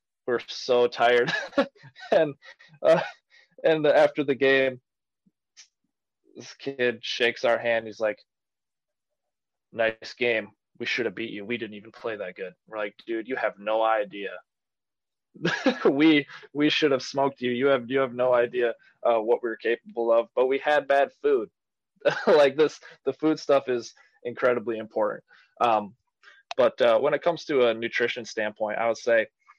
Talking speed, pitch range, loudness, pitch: 160 wpm, 115-140 Hz, -25 LUFS, 125 Hz